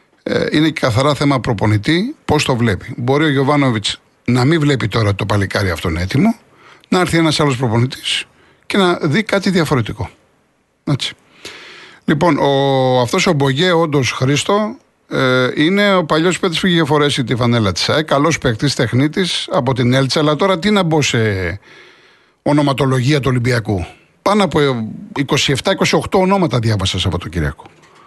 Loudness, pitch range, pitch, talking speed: -15 LUFS, 125-175 Hz, 145 Hz, 155 wpm